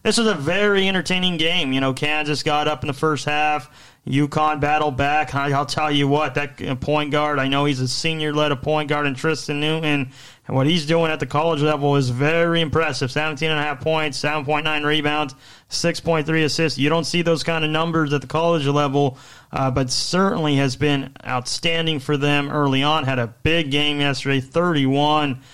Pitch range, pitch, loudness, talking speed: 140-160 Hz, 150 Hz, -20 LUFS, 205 wpm